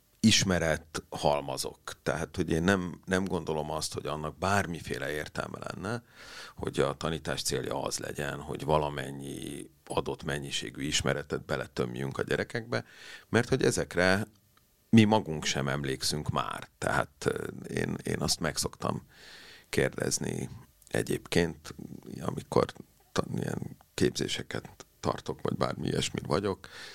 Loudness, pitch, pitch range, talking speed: -31 LUFS, 80 Hz, 70-95 Hz, 115 wpm